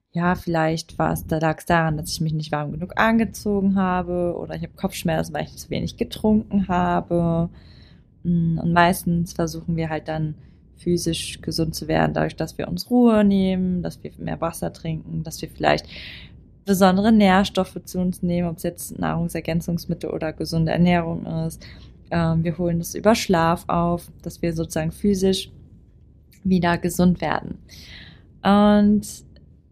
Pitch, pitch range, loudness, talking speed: 170 Hz, 160-185 Hz, -22 LUFS, 155 wpm